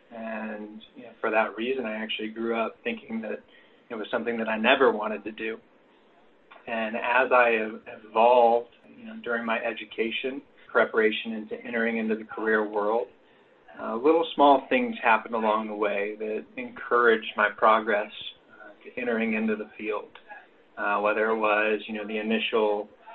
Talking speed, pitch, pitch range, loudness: 165 wpm, 110 Hz, 110-120 Hz, -26 LUFS